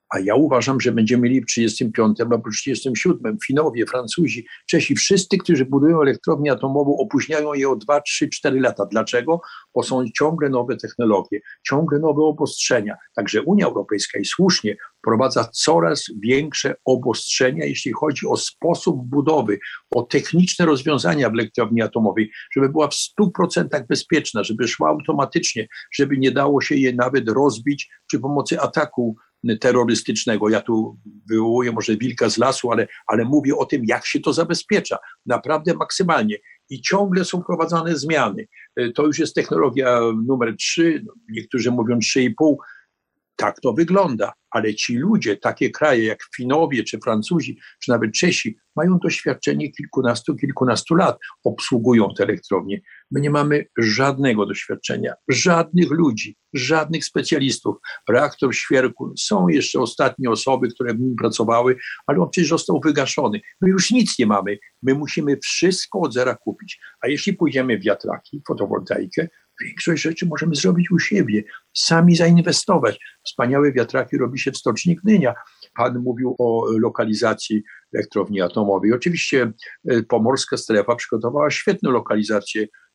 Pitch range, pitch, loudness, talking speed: 120-165 Hz, 140 Hz, -19 LUFS, 140 wpm